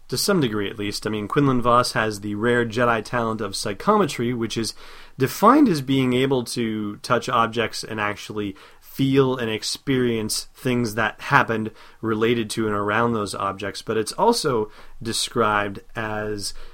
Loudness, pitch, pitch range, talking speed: -22 LUFS, 115 Hz, 105-125 Hz, 160 wpm